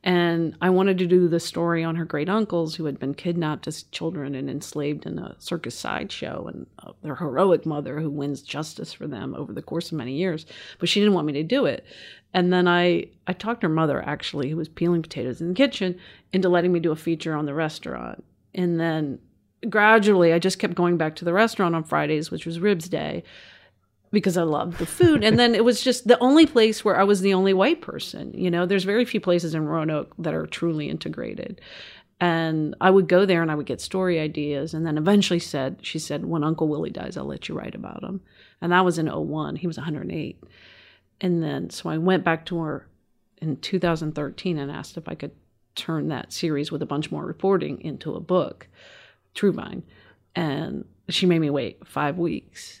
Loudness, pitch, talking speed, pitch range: -23 LUFS, 170 Hz, 215 wpm, 155-190 Hz